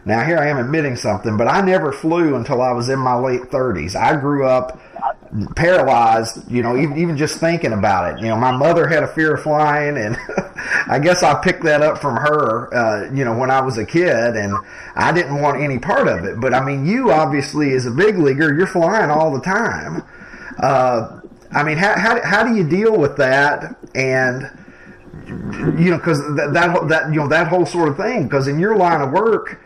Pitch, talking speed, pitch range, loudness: 150 Hz, 220 wpm, 130-165 Hz, -16 LUFS